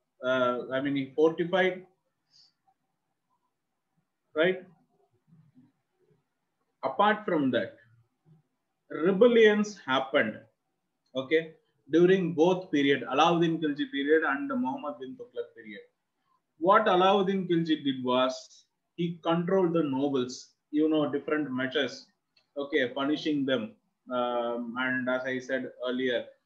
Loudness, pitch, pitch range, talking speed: -27 LUFS, 155 Hz, 130-185 Hz, 100 wpm